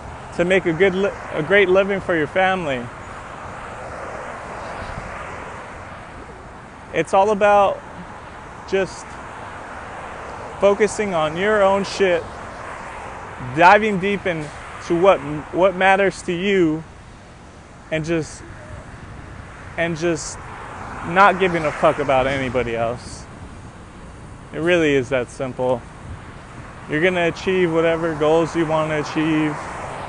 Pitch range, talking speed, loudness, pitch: 135-190 Hz, 110 wpm, -19 LUFS, 165 Hz